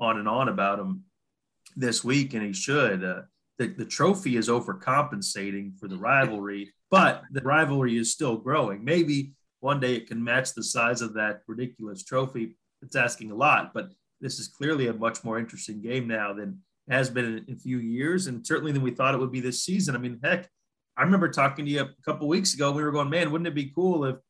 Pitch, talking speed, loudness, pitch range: 130 Hz, 220 wpm, -26 LUFS, 115-150 Hz